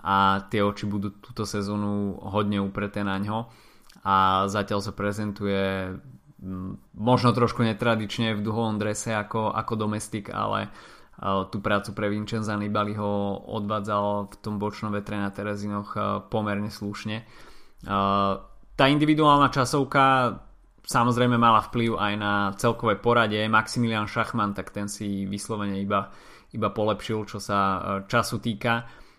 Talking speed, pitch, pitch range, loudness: 135 wpm, 105 Hz, 100-115 Hz, -25 LUFS